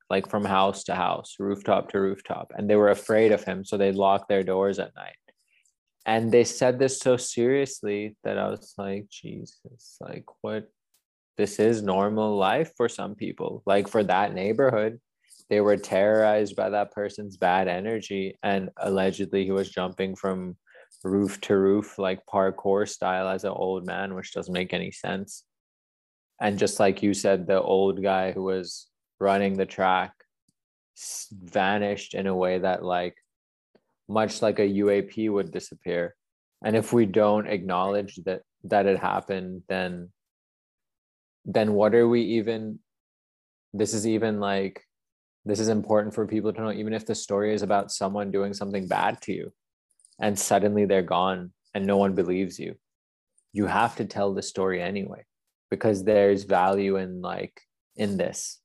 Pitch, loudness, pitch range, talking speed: 100 Hz, -26 LUFS, 95-105 Hz, 165 wpm